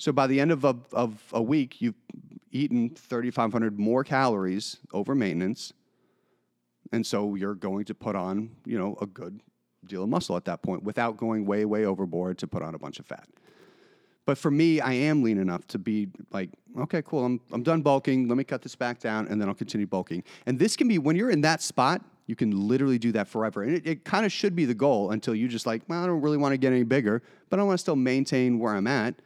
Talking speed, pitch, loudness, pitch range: 240 wpm, 120 Hz, -27 LUFS, 105-145 Hz